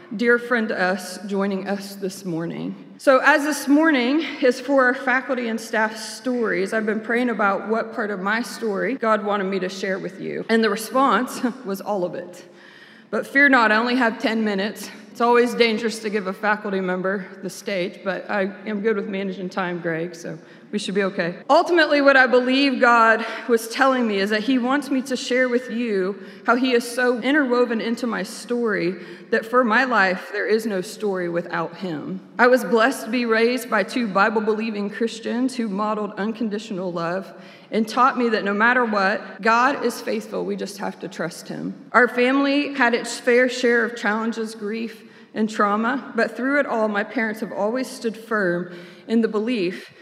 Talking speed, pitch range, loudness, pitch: 195 wpm, 200-245 Hz, -21 LUFS, 225 Hz